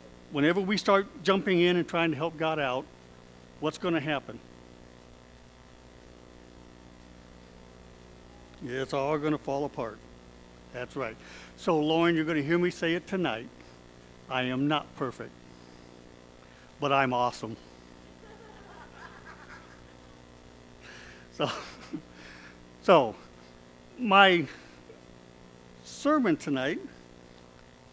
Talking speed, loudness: 95 wpm, -28 LUFS